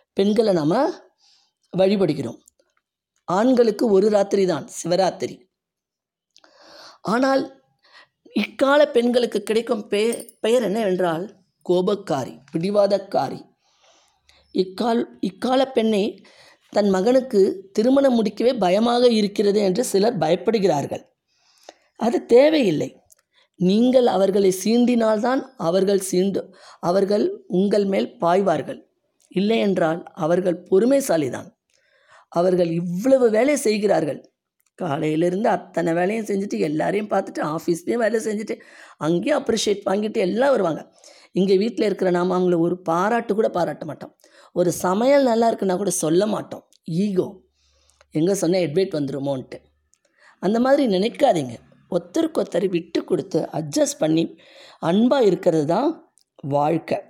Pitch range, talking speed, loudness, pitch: 180-235 Hz, 100 wpm, -21 LUFS, 200 Hz